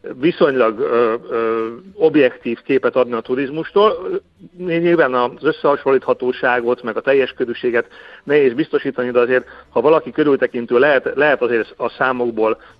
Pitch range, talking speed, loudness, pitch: 125-165 Hz, 125 wpm, -17 LUFS, 130 Hz